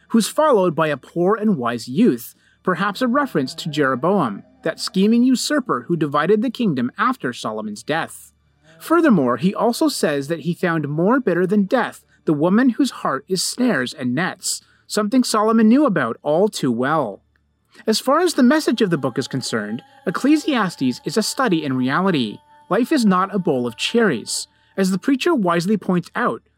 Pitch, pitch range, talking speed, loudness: 200 Hz, 160-245 Hz, 175 wpm, -19 LUFS